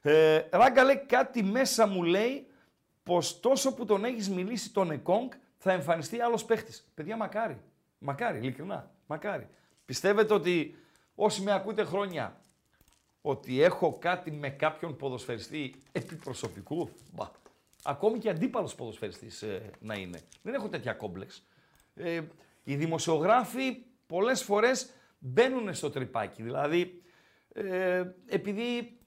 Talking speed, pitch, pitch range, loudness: 120 wpm, 185 Hz, 155-230 Hz, -30 LUFS